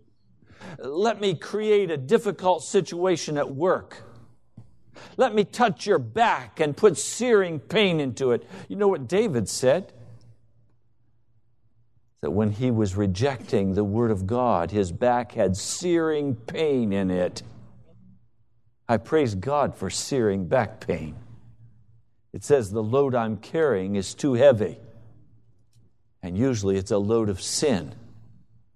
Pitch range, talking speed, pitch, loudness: 110-145 Hz, 130 wpm, 115 Hz, -24 LUFS